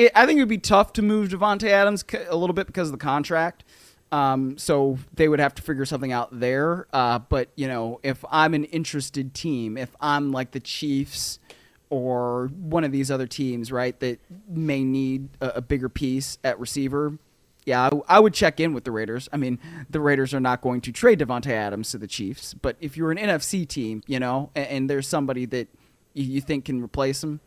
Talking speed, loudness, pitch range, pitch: 215 wpm, -24 LUFS, 125-160 Hz, 140 Hz